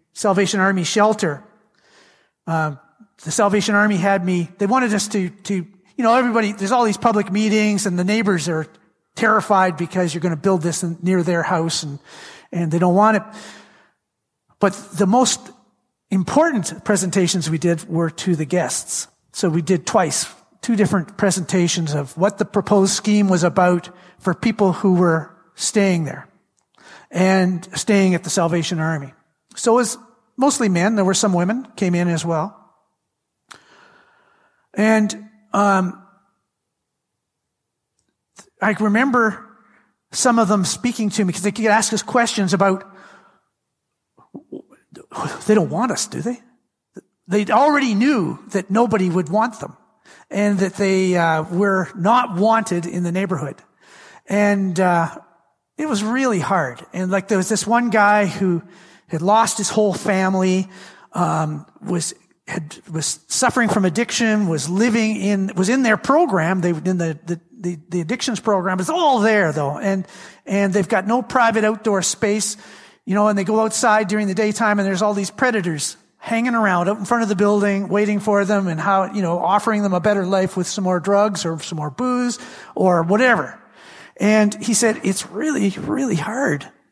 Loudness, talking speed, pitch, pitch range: -19 LUFS, 165 wpm, 200 Hz, 180-215 Hz